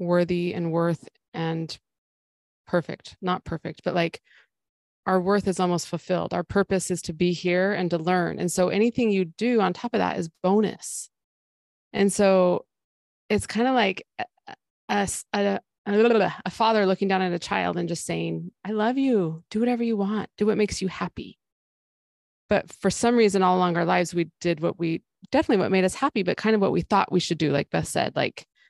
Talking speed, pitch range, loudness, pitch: 200 wpm, 170-210 Hz, -24 LUFS, 185 Hz